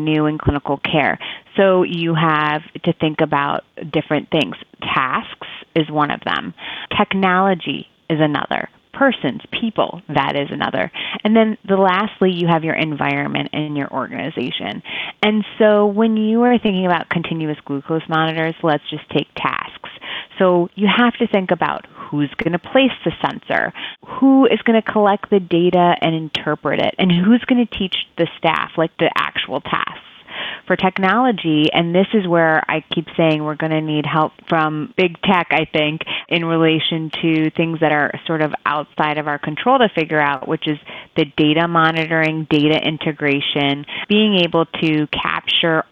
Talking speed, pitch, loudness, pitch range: 170 wpm, 165 Hz, -17 LUFS, 155-190 Hz